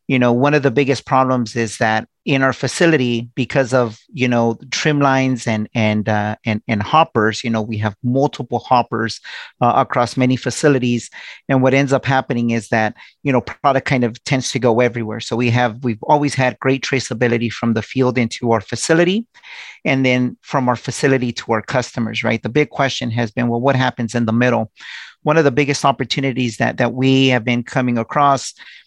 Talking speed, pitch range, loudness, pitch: 200 wpm, 115-135 Hz, -17 LUFS, 125 Hz